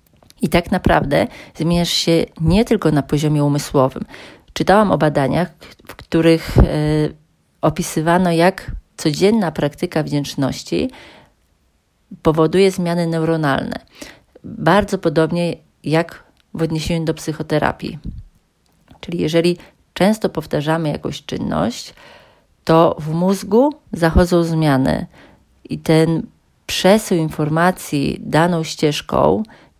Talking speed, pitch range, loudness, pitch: 95 wpm, 155-175 Hz, -17 LUFS, 165 Hz